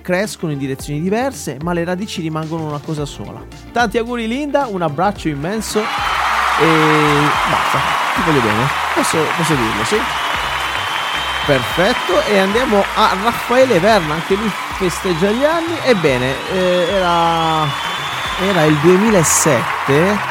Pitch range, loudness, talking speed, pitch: 160-220 Hz, -15 LUFS, 125 wpm, 180 Hz